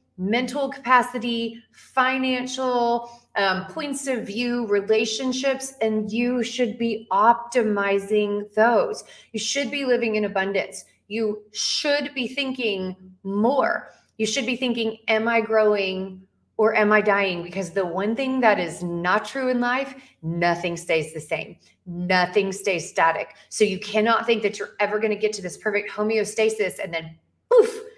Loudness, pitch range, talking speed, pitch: -23 LUFS, 195-245 Hz, 150 wpm, 220 Hz